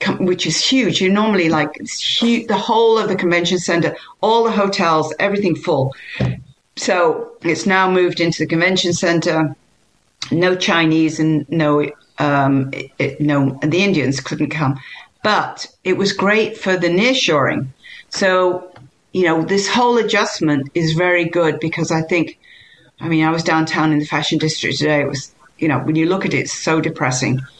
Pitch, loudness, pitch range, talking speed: 165 Hz, -17 LUFS, 155-190 Hz, 180 wpm